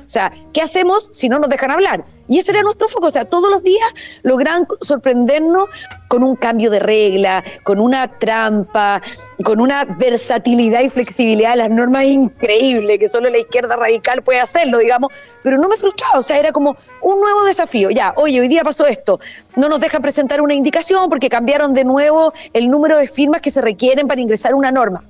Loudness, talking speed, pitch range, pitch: -14 LUFS, 200 wpm, 240-330 Hz, 275 Hz